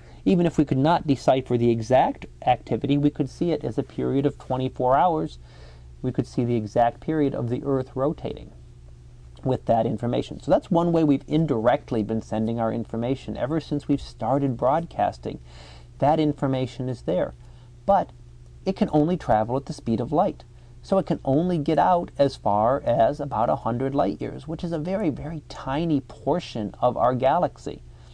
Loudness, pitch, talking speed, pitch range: -24 LUFS, 130 Hz, 180 wpm, 115-150 Hz